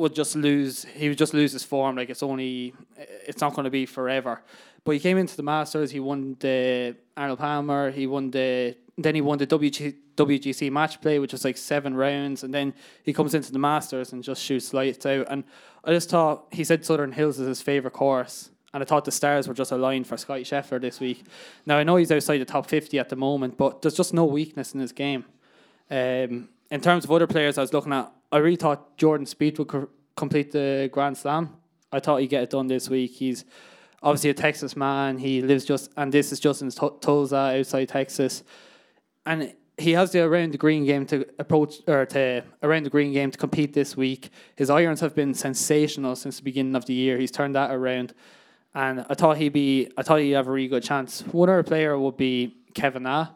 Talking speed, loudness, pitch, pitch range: 230 wpm, -24 LUFS, 140 Hz, 135-150 Hz